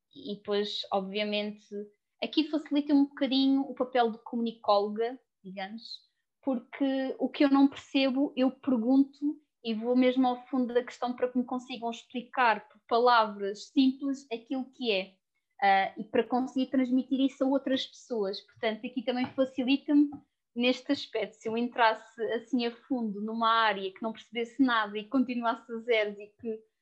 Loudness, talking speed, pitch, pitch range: -29 LUFS, 160 wpm, 245 Hz, 220-265 Hz